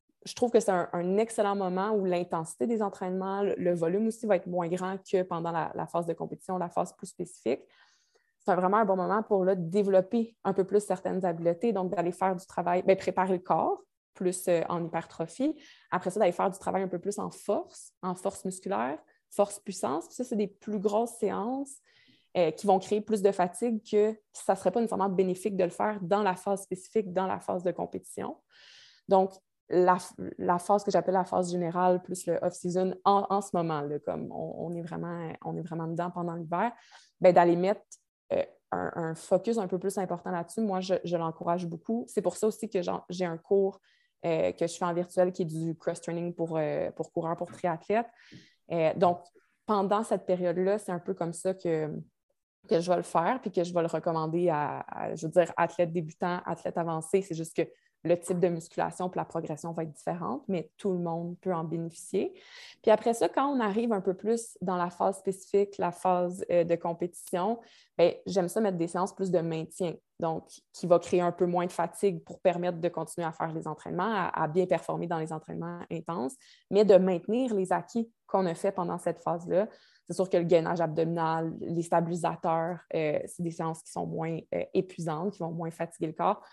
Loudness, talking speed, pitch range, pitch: -30 LUFS, 215 wpm, 170-200 Hz, 180 Hz